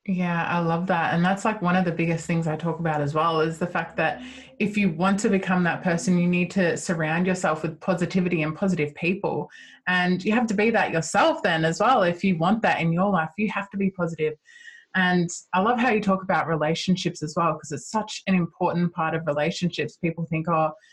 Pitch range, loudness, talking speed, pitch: 165-195 Hz, -24 LUFS, 230 wpm, 175 Hz